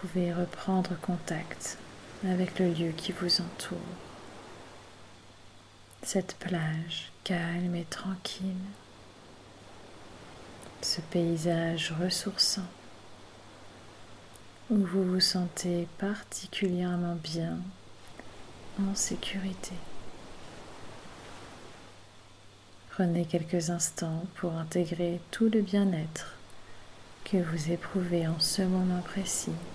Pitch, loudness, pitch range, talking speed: 170 Hz, -31 LUFS, 110-185 Hz, 85 wpm